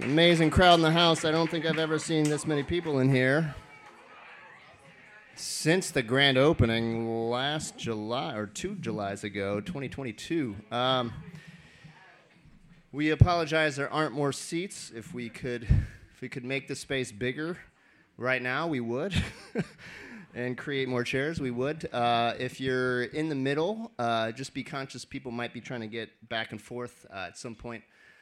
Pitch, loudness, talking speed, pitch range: 130 Hz, -29 LUFS, 165 wpm, 120-155 Hz